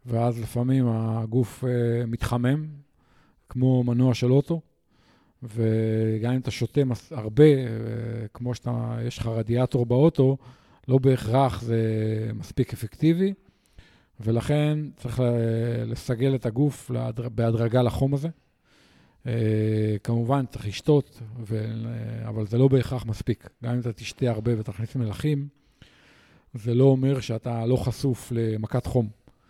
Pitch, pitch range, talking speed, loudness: 120 Hz, 115-130 Hz, 115 wpm, -25 LUFS